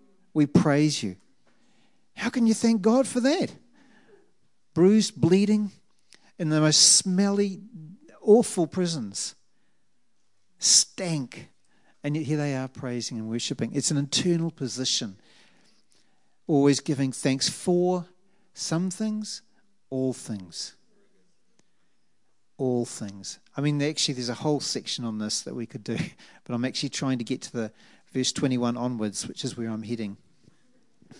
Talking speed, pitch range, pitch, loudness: 135 wpm, 125-190 Hz, 150 Hz, -25 LUFS